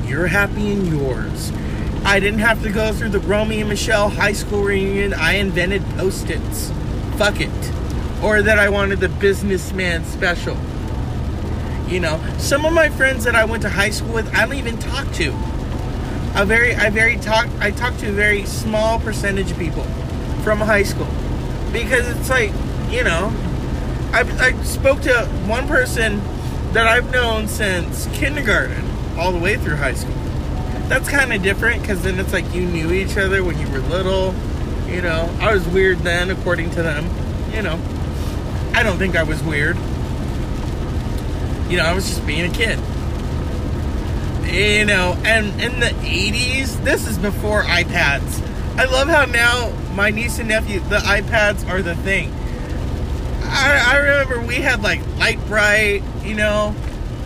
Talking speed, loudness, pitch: 170 wpm, -18 LUFS, 100 Hz